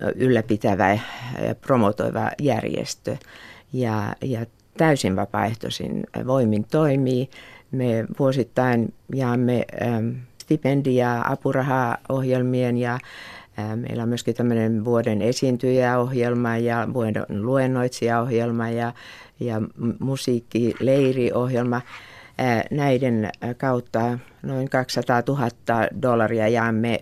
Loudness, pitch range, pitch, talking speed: -23 LUFS, 115-130 Hz, 120 Hz, 80 wpm